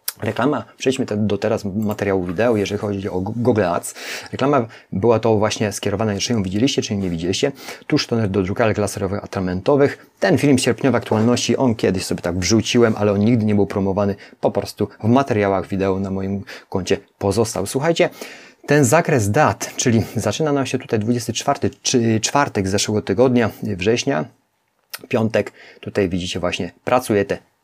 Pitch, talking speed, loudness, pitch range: 105 Hz, 160 wpm, -19 LUFS, 100-120 Hz